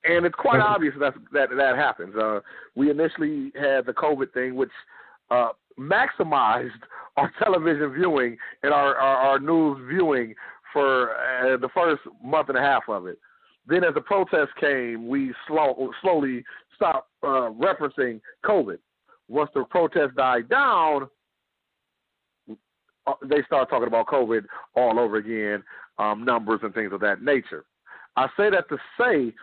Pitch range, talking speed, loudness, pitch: 120-150 Hz, 150 wpm, -23 LUFS, 135 Hz